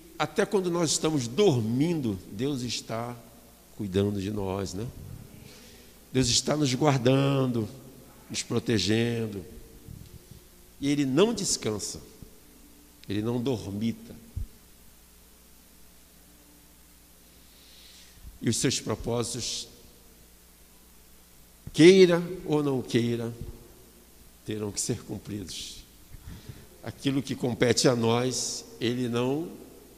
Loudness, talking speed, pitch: -27 LUFS, 85 wpm, 115 Hz